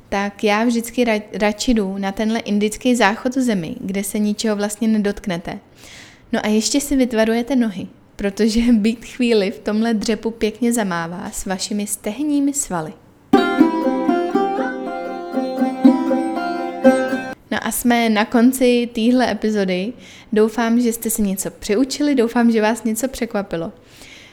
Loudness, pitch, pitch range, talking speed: -19 LUFS, 225 Hz, 205-245 Hz, 125 wpm